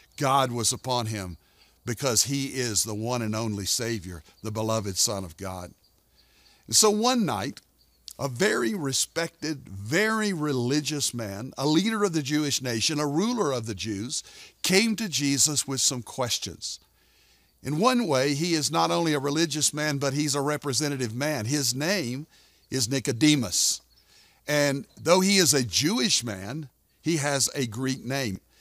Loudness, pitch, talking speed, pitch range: -25 LUFS, 135 Hz, 155 wpm, 110-150 Hz